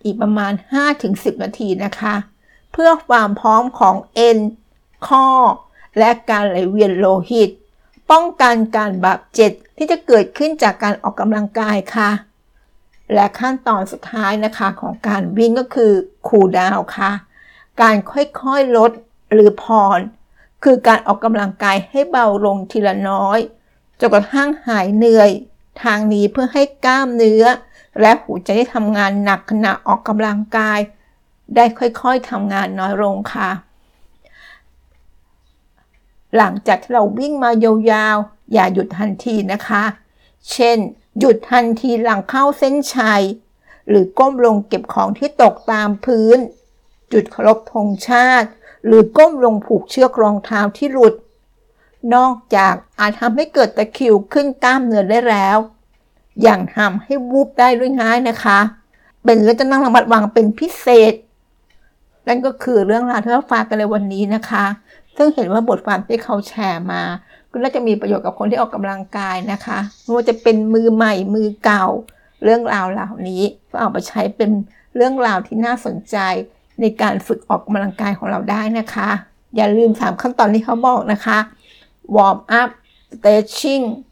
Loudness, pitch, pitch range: -15 LUFS, 220 Hz, 205-240 Hz